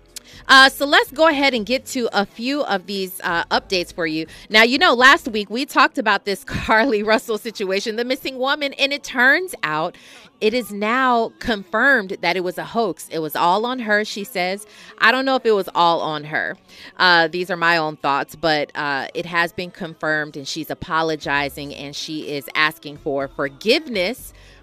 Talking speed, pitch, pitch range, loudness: 195 wpm, 200 Hz, 165-245 Hz, -18 LUFS